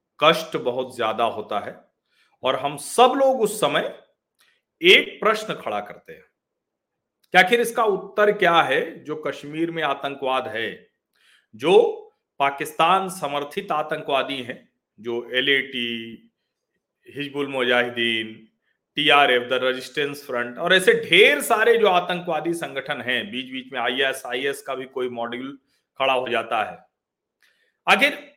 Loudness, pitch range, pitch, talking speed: -21 LUFS, 130-200 Hz, 145 Hz, 140 wpm